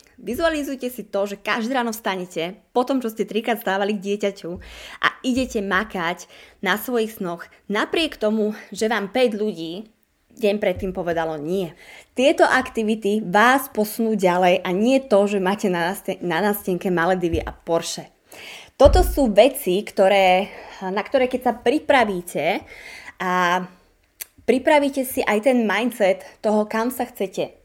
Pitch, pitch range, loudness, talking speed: 210 Hz, 185-245 Hz, -21 LUFS, 140 wpm